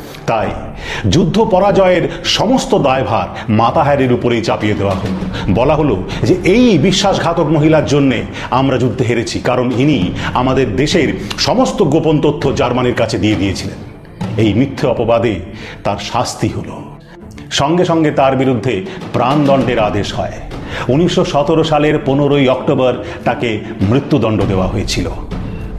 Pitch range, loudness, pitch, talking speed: 110-150 Hz, -14 LUFS, 130 Hz, 120 wpm